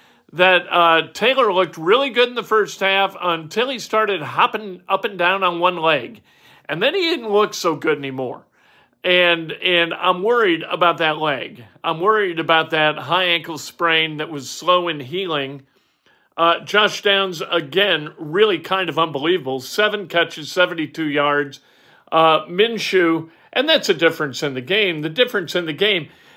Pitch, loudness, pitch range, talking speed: 175 Hz, -18 LUFS, 155-195 Hz, 165 wpm